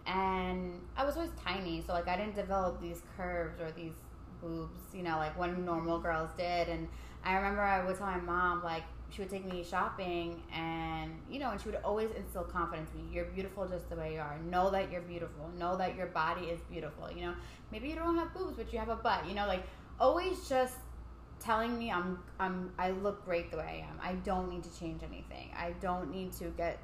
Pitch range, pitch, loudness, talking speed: 170-195 Hz, 180 Hz, -37 LUFS, 230 wpm